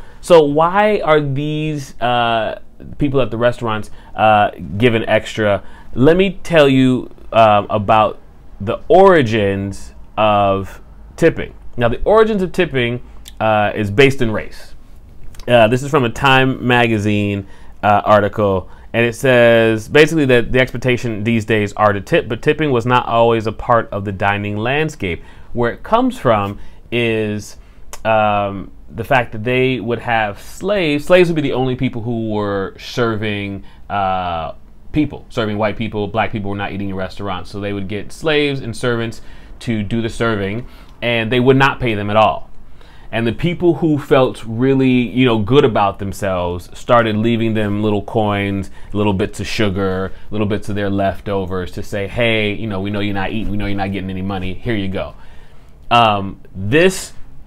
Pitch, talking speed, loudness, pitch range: 110 Hz, 170 wpm, -16 LUFS, 100-125 Hz